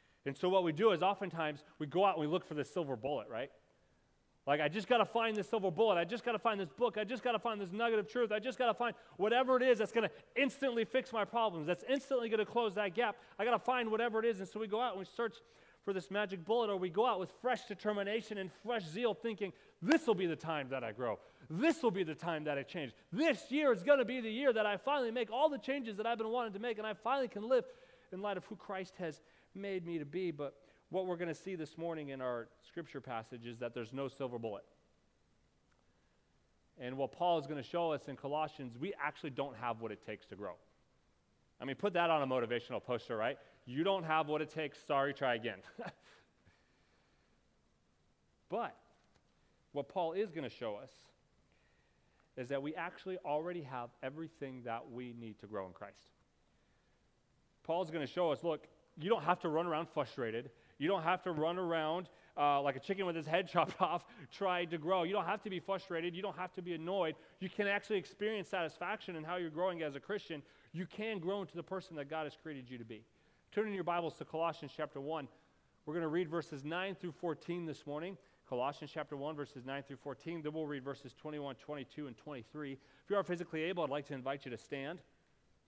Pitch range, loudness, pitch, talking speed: 145-210 Hz, -38 LUFS, 175 Hz, 235 wpm